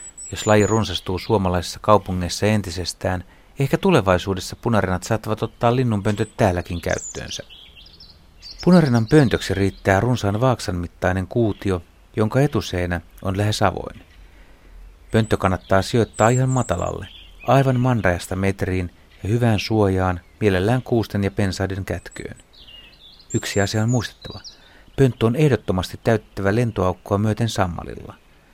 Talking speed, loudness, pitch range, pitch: 110 wpm, -21 LUFS, 90-110 Hz, 100 Hz